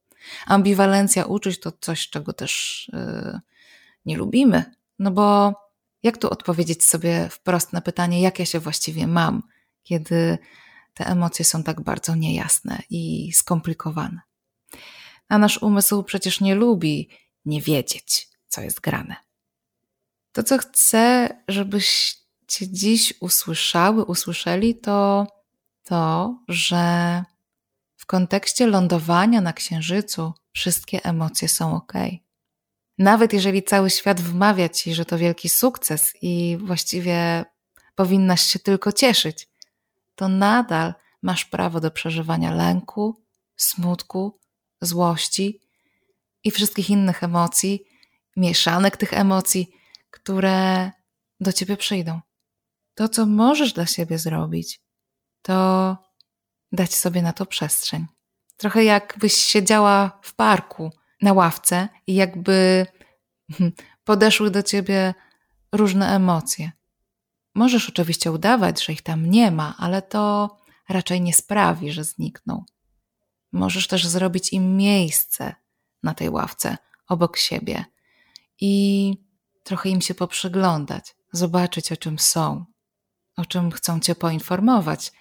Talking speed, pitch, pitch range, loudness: 115 wpm, 185 Hz, 170-200 Hz, -20 LUFS